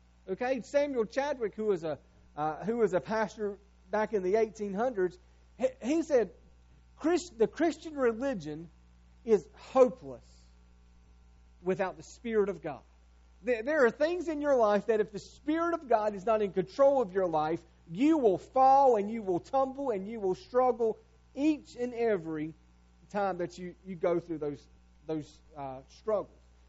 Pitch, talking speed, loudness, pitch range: 200 Hz, 165 wpm, -31 LUFS, 150-250 Hz